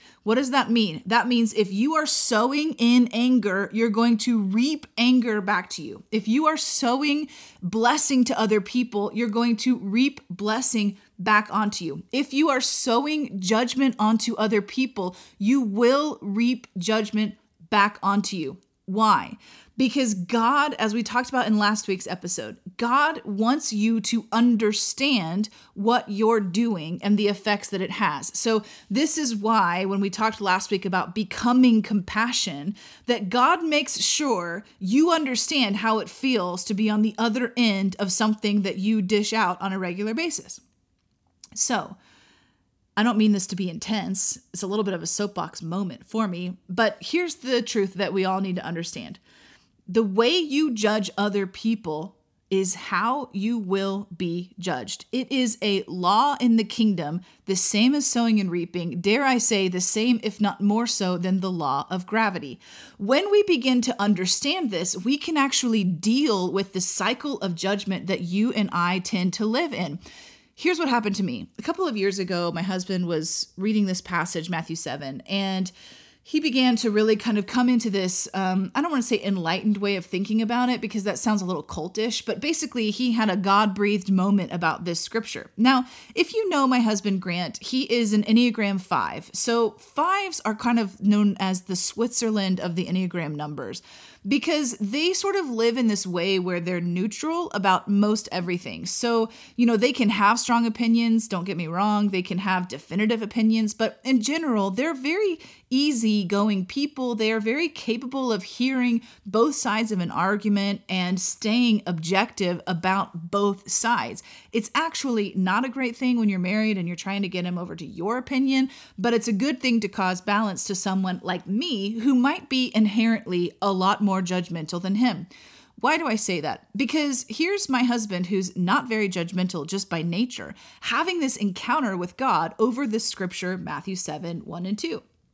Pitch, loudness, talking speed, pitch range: 215 Hz, -23 LUFS, 180 wpm, 190-240 Hz